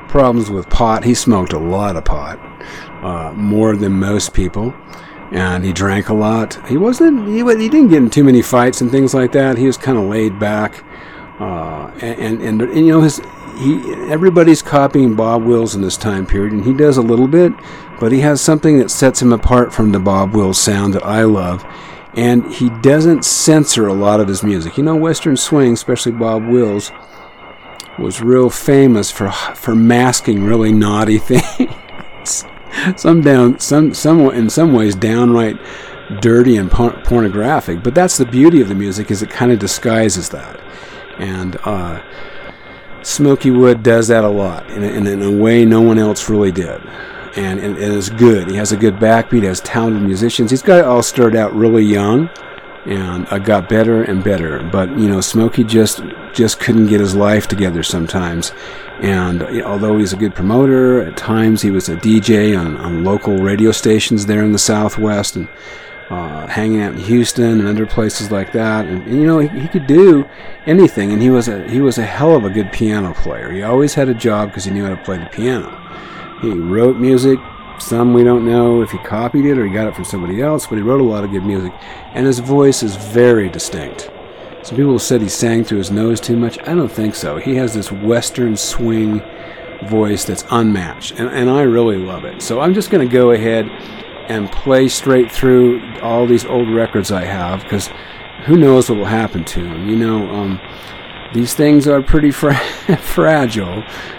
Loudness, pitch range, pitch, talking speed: -13 LUFS, 100-130 Hz, 115 Hz, 200 wpm